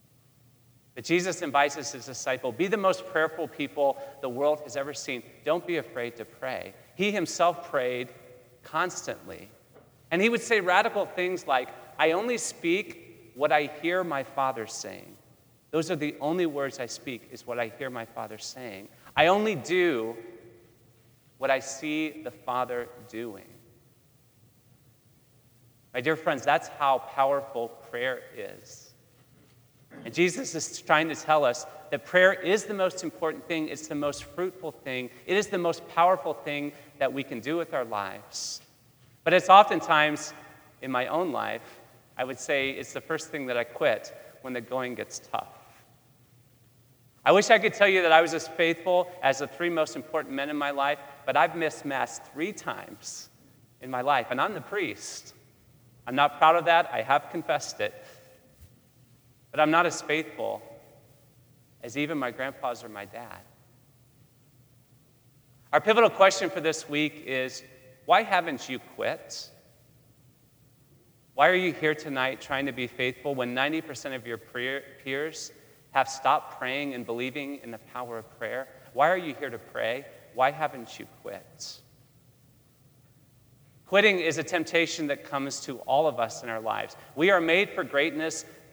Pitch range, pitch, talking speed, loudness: 125-155 Hz, 135 Hz, 165 wpm, -27 LUFS